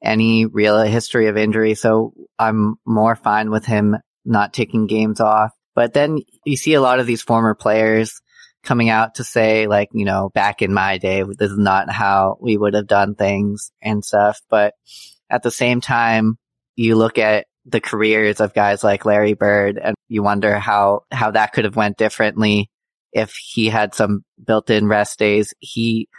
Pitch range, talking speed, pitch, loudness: 105-115 Hz, 185 wpm, 110 Hz, -17 LUFS